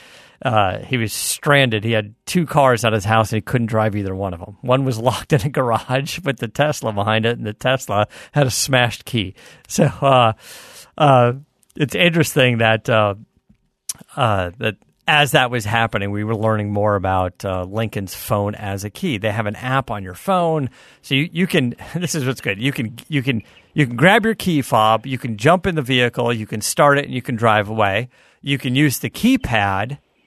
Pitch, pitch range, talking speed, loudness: 120 Hz, 110-140 Hz, 210 wpm, -18 LUFS